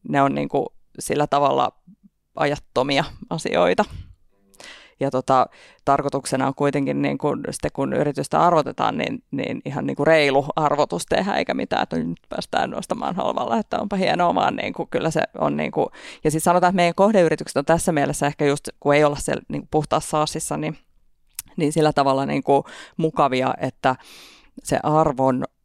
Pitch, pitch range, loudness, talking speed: 145 Hz, 135-155 Hz, -21 LUFS, 155 wpm